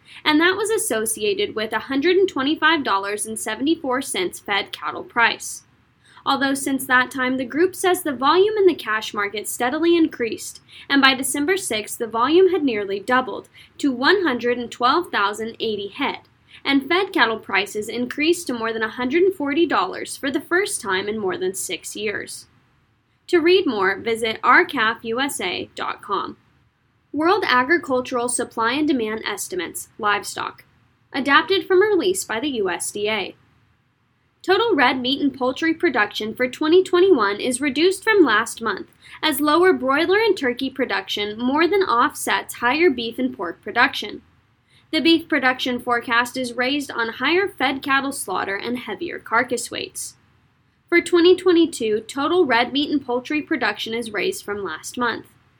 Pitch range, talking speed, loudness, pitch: 230-340 Hz, 140 wpm, -20 LUFS, 270 Hz